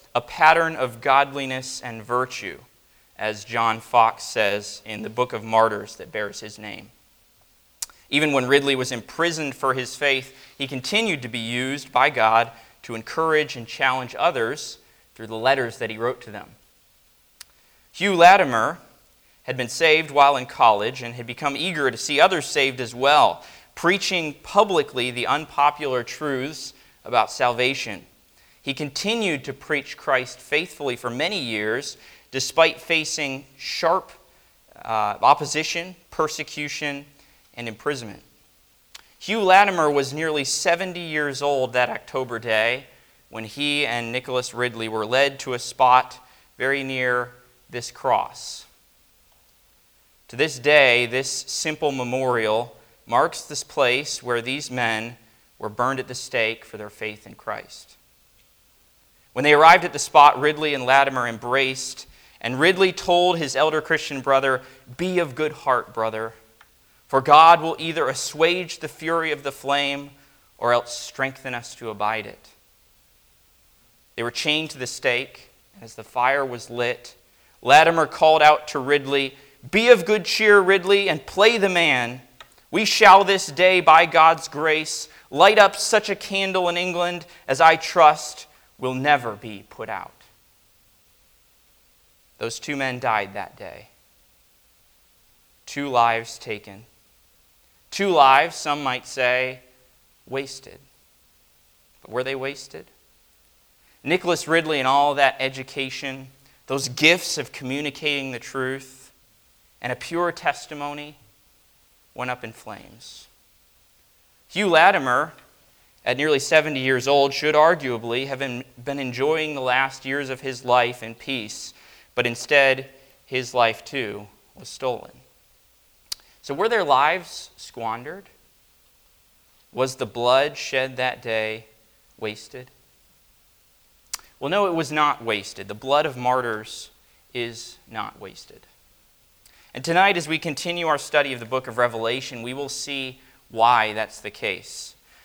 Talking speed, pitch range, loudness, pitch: 135 wpm, 120-150 Hz, -21 LUFS, 135 Hz